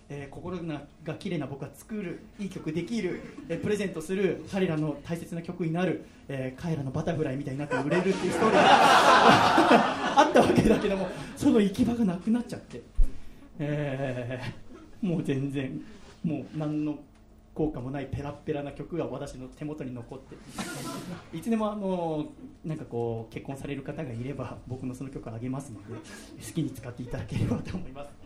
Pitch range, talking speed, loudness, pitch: 135-175 Hz, 360 characters per minute, -28 LUFS, 150 Hz